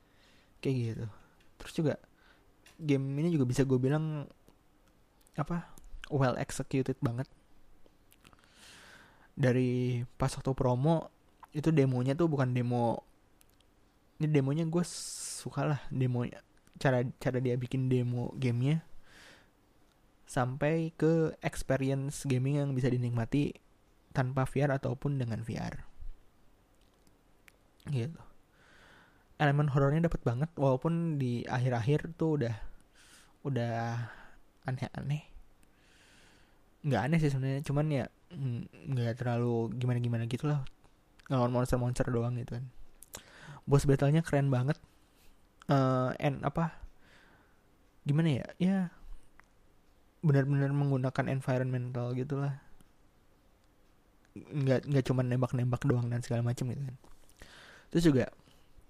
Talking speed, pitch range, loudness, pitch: 105 wpm, 120-145 Hz, -32 LUFS, 130 Hz